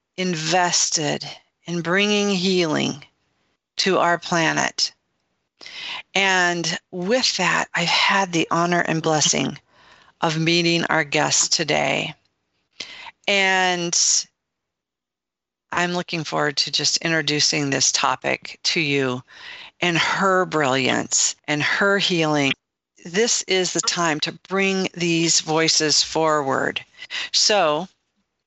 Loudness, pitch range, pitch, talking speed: -19 LUFS, 150-185 Hz, 170 Hz, 100 wpm